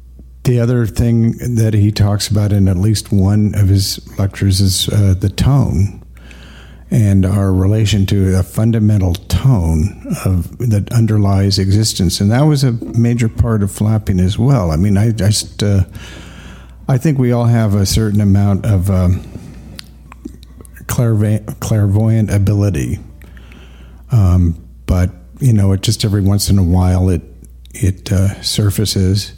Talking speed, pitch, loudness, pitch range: 150 wpm, 100 Hz, -14 LUFS, 90-110 Hz